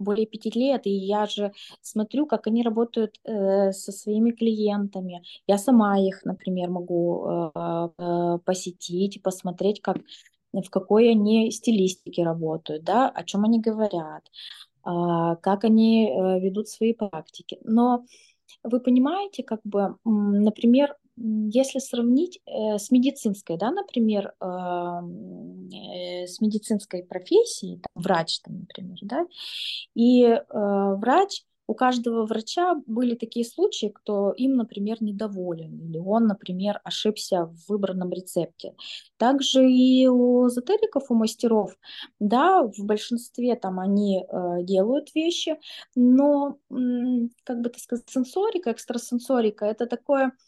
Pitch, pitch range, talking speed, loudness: 215 Hz, 190-245 Hz, 115 wpm, -24 LUFS